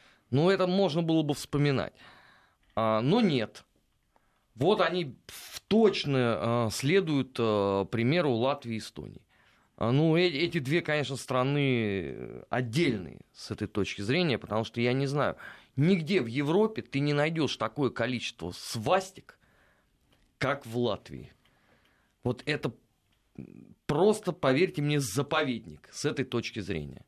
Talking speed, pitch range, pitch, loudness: 130 wpm, 115-155 Hz, 135 Hz, -29 LUFS